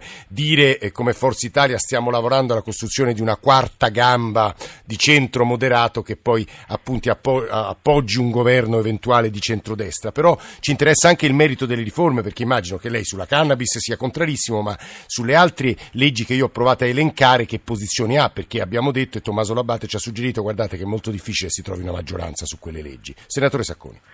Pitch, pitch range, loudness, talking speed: 120 Hz, 110-130 Hz, -18 LUFS, 185 wpm